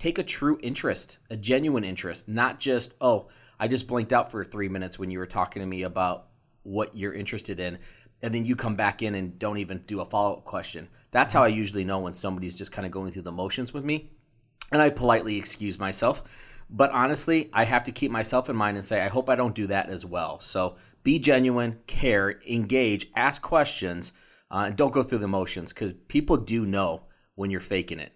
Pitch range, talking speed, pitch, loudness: 95-125 Hz, 220 wpm, 105 Hz, -26 LUFS